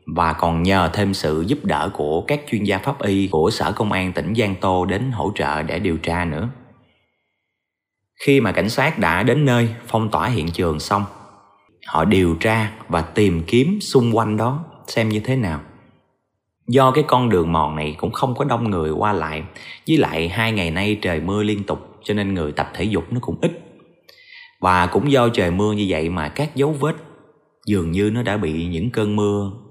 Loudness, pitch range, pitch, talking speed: -20 LUFS, 85-120 Hz, 105 Hz, 205 wpm